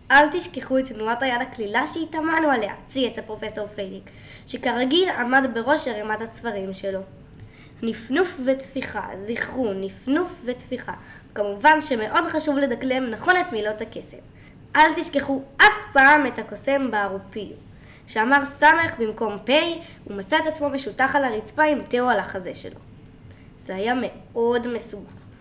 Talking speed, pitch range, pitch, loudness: 135 wpm, 220-290 Hz, 255 Hz, -22 LUFS